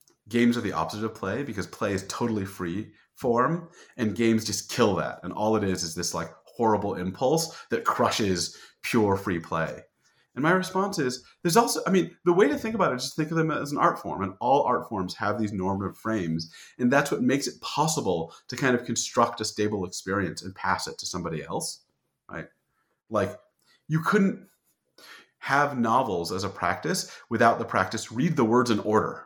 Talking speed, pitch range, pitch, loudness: 200 wpm, 100-155 Hz, 115 Hz, -26 LUFS